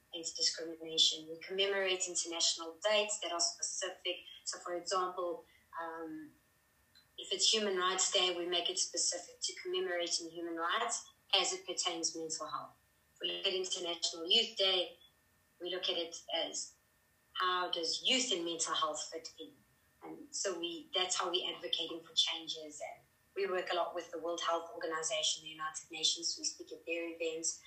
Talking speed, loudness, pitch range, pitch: 165 wpm, -35 LUFS, 165-185 Hz, 170 Hz